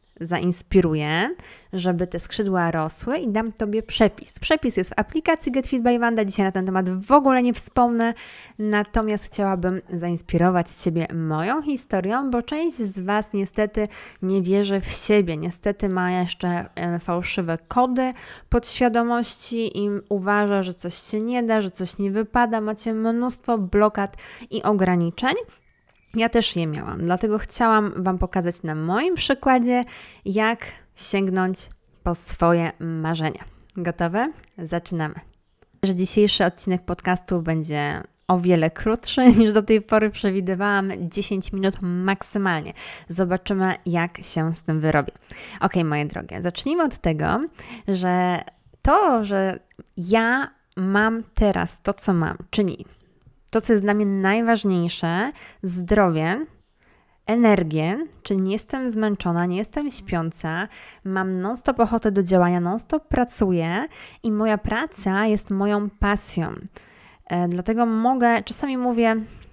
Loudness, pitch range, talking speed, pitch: -22 LUFS, 180-225 Hz, 130 wpm, 200 Hz